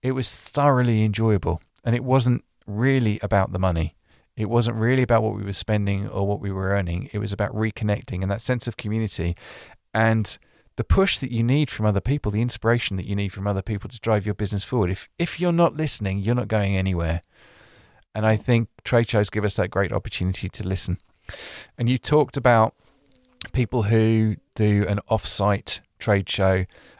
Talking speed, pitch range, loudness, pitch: 195 wpm, 100-120 Hz, -22 LUFS, 110 Hz